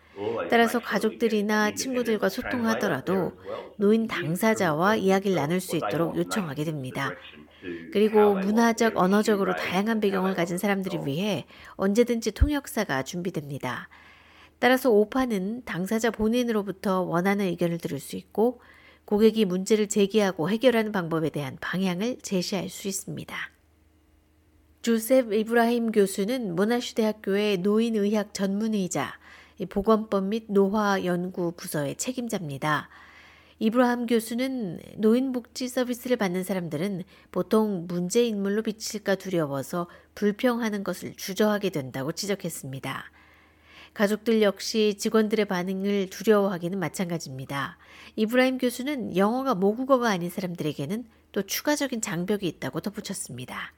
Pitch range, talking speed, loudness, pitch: 175-225 Hz, 330 characters per minute, -26 LUFS, 200 Hz